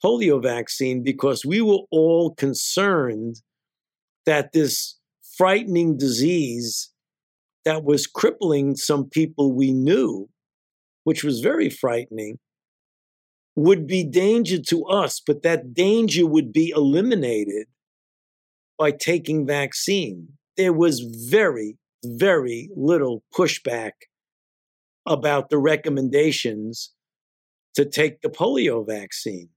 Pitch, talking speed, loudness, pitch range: 145 Hz, 100 wpm, -21 LUFS, 125-165 Hz